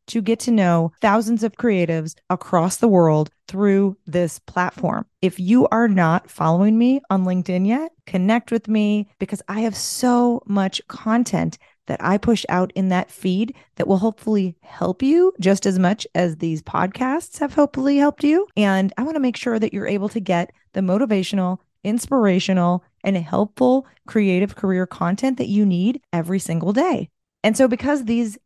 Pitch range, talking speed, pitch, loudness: 180-235 Hz, 175 wpm, 200 Hz, -20 LUFS